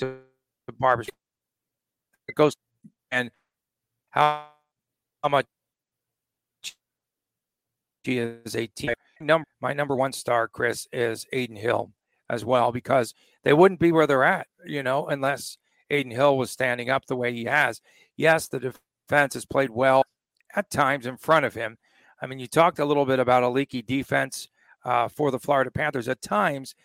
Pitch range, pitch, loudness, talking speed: 120-145 Hz, 130 Hz, -24 LUFS, 150 wpm